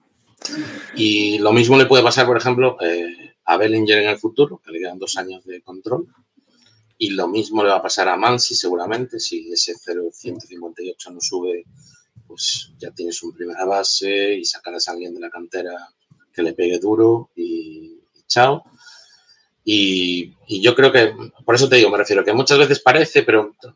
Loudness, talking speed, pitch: -17 LUFS, 180 wpm, 125 Hz